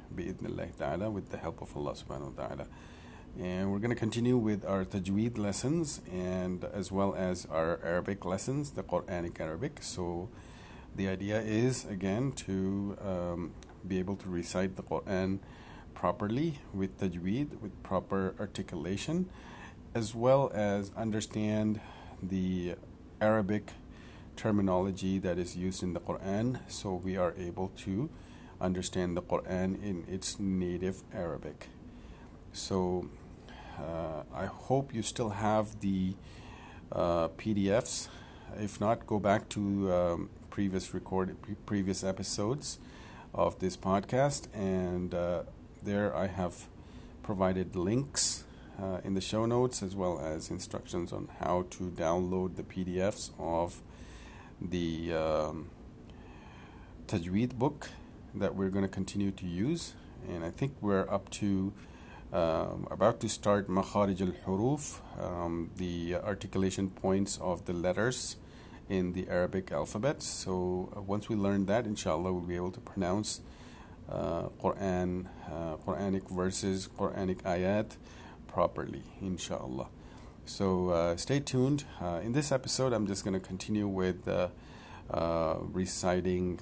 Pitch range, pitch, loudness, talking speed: 90-105 Hz, 95 Hz, -32 LUFS, 130 wpm